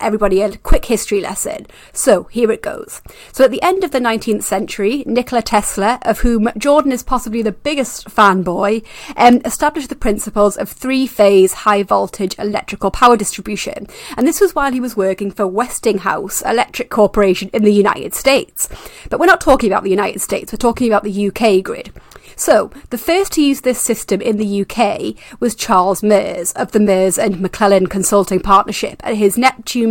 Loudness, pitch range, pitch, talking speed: -15 LUFS, 200-245 Hz, 220 Hz, 180 wpm